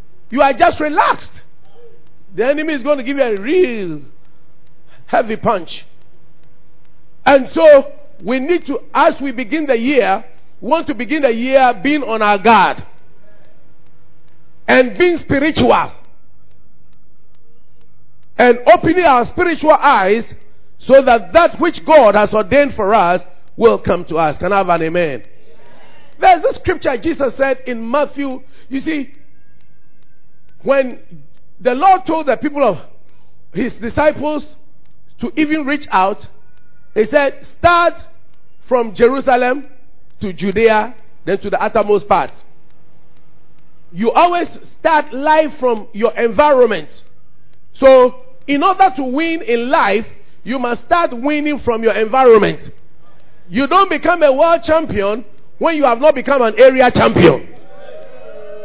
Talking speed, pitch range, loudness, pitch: 135 wpm, 215-305 Hz, -13 LUFS, 265 Hz